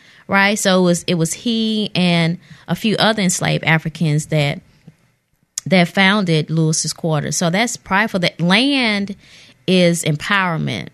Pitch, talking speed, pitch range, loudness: 175 Hz, 135 wpm, 160-195 Hz, -16 LUFS